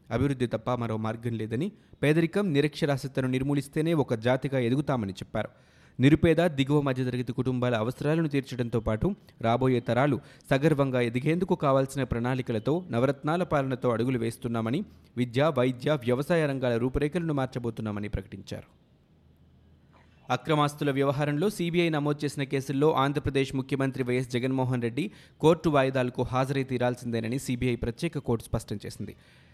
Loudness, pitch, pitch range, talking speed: -28 LUFS, 130 Hz, 120-145 Hz, 115 wpm